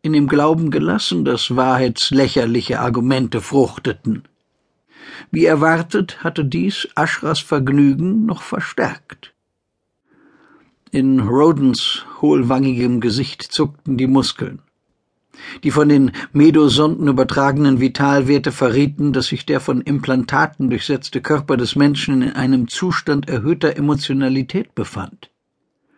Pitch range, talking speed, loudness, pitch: 130-150 Hz, 105 wpm, -16 LUFS, 140 Hz